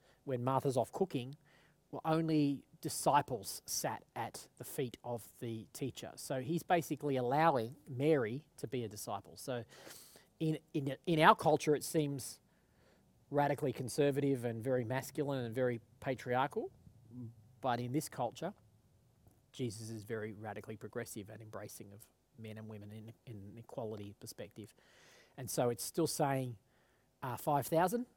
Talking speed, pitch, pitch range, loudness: 140 wpm, 130 Hz, 115-145 Hz, -37 LUFS